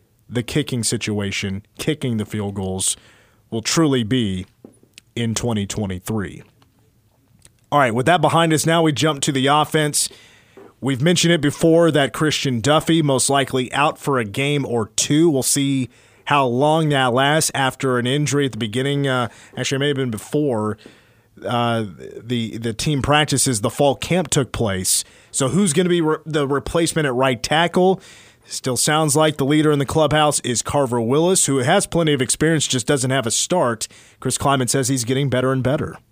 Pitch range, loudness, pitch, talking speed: 115-150 Hz, -19 LUFS, 135 Hz, 180 wpm